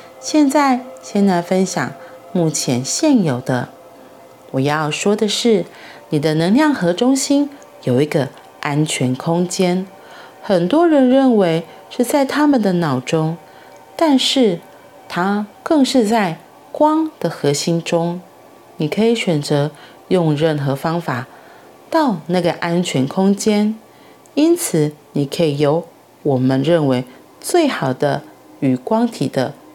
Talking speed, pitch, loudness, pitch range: 175 characters per minute, 175 Hz, -17 LUFS, 150-245 Hz